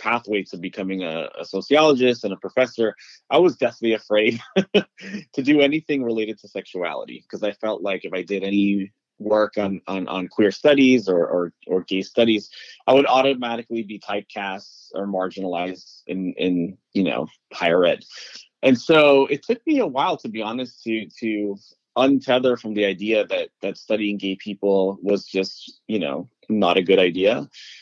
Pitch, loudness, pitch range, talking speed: 110 Hz, -21 LUFS, 100-135 Hz, 175 wpm